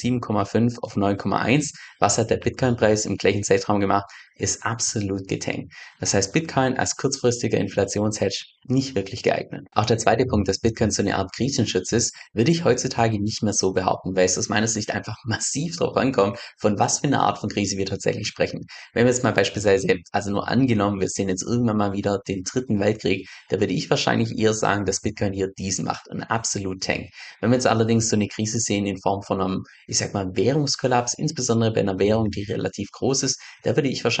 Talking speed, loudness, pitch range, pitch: 210 wpm, -23 LUFS, 100-120 Hz, 105 Hz